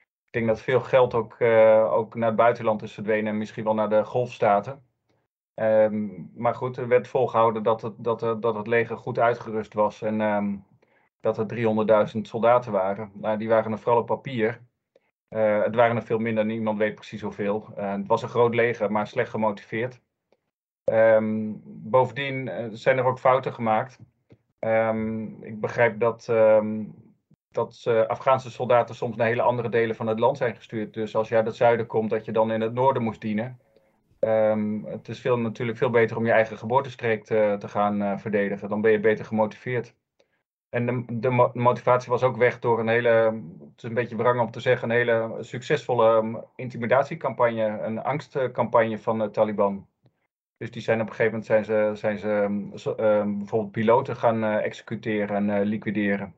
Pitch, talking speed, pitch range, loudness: 110 Hz, 190 wpm, 110-120 Hz, -24 LUFS